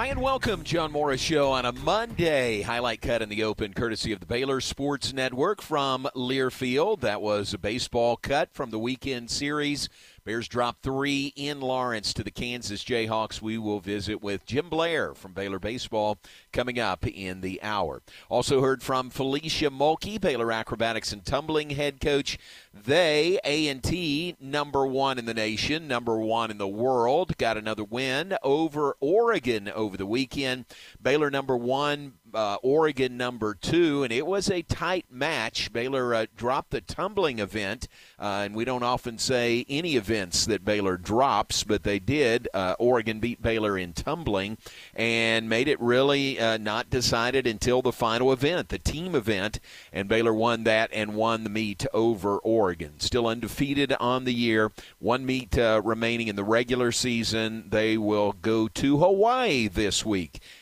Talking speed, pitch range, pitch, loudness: 165 wpm, 110-140 Hz, 120 Hz, -26 LUFS